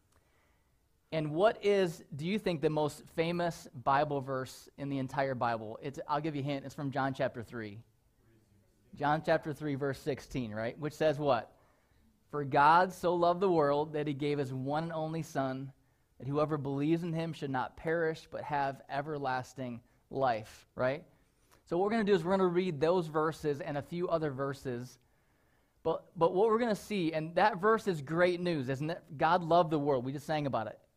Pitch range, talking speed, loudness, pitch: 135-165 Hz, 200 wpm, -33 LUFS, 150 Hz